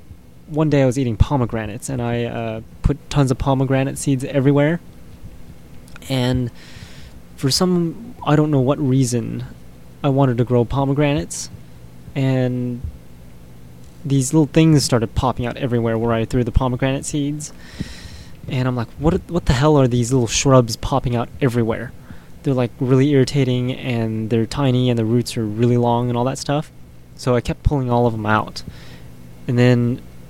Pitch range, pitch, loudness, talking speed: 110-140 Hz, 125 Hz, -19 LUFS, 165 wpm